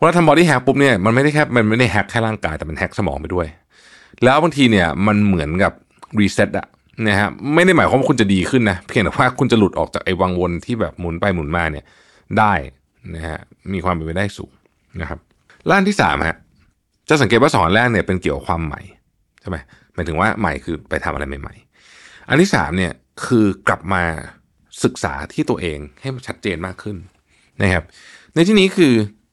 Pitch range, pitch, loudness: 85-120 Hz, 100 Hz, -17 LUFS